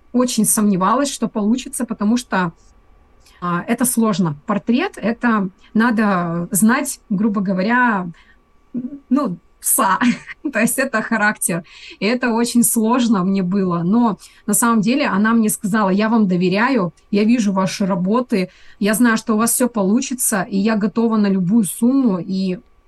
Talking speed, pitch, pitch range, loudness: 145 wpm, 220 Hz, 195-240 Hz, -17 LUFS